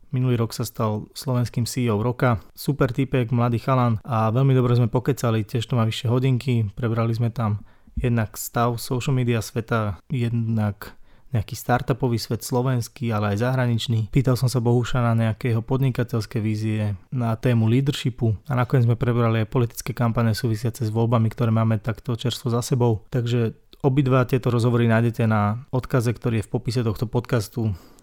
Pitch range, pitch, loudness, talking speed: 115-125 Hz, 120 Hz, -23 LUFS, 165 wpm